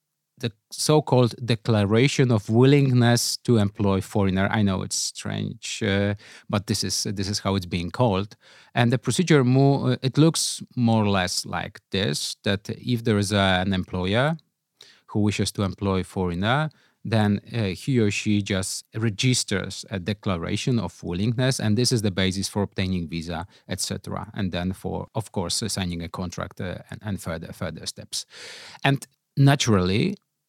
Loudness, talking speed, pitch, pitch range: -24 LUFS, 160 wpm, 105 Hz, 95-120 Hz